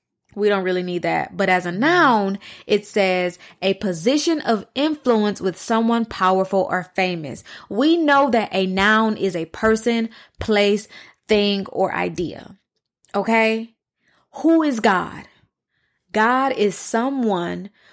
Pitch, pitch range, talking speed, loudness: 210 Hz, 190-230 Hz, 130 wpm, -20 LUFS